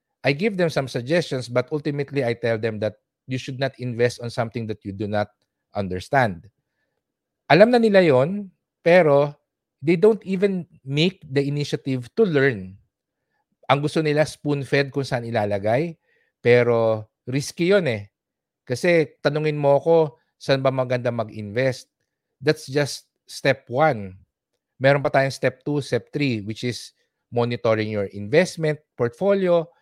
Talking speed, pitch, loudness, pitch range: 145 wpm, 135 Hz, -22 LUFS, 120-155 Hz